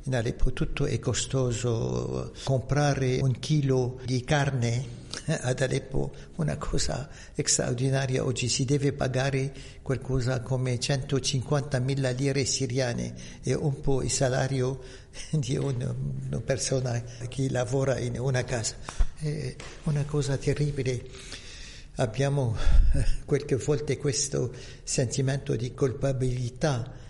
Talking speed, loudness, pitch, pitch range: 110 wpm, -28 LUFS, 130 Hz, 125-140 Hz